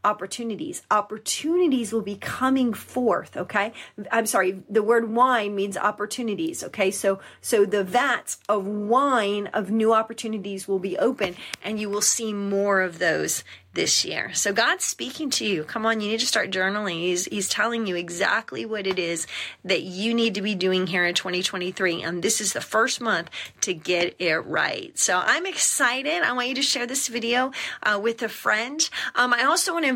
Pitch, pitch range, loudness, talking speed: 210 Hz, 190-240 Hz, -23 LUFS, 190 wpm